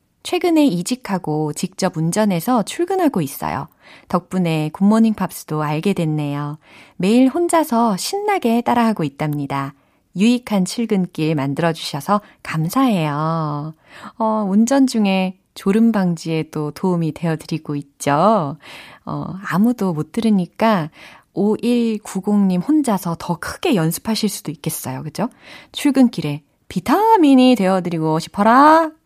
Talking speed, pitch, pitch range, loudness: 270 characters per minute, 190 Hz, 160-230 Hz, -18 LUFS